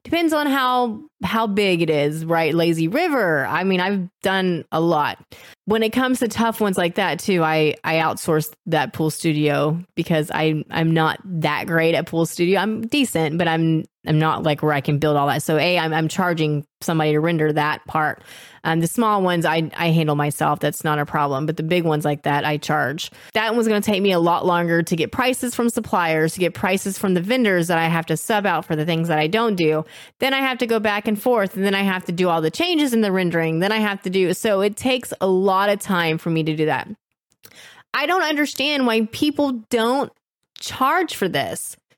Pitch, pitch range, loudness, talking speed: 175 Hz, 155-215 Hz, -20 LUFS, 235 wpm